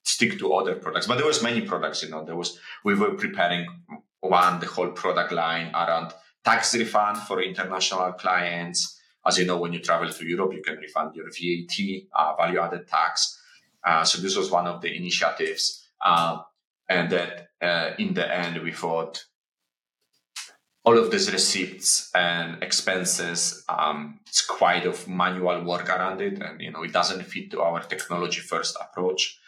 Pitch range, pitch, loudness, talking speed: 85-95 Hz, 85 Hz, -24 LUFS, 175 wpm